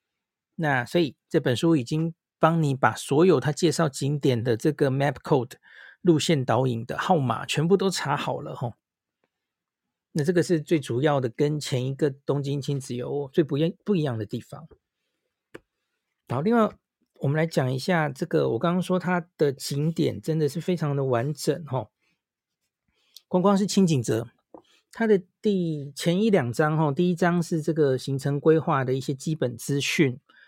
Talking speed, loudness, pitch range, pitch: 260 characters per minute, -25 LUFS, 135-170 Hz, 155 Hz